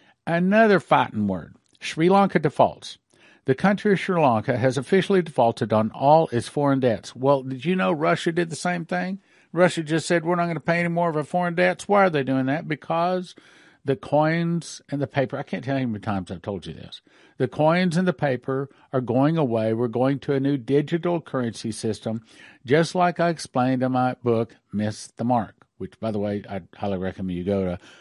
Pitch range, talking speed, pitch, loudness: 120-170 Hz, 215 wpm, 140 Hz, -23 LUFS